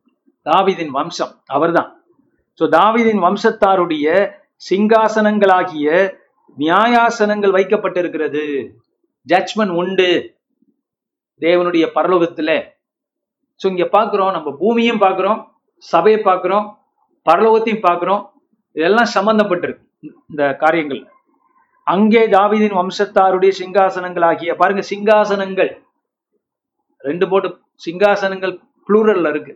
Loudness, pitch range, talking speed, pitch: -15 LUFS, 180-225 Hz, 80 wpm, 195 Hz